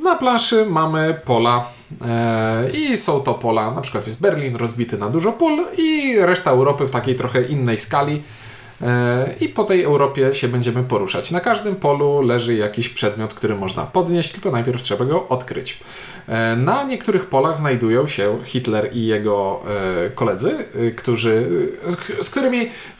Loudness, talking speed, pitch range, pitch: -19 LUFS, 165 wpm, 115-180 Hz, 130 Hz